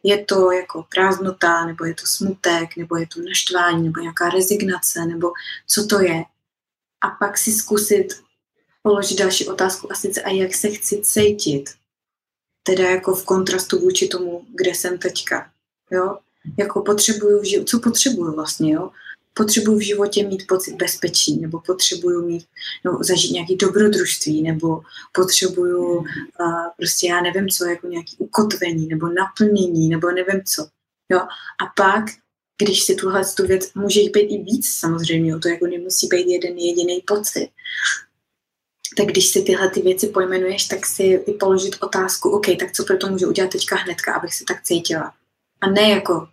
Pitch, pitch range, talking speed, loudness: 185 Hz, 175-200 Hz, 165 wpm, -19 LUFS